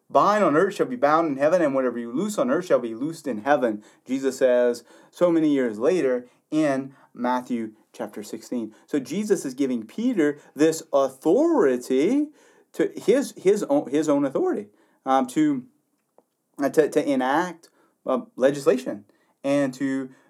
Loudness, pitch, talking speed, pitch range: -23 LUFS, 140 Hz, 155 wpm, 125-165 Hz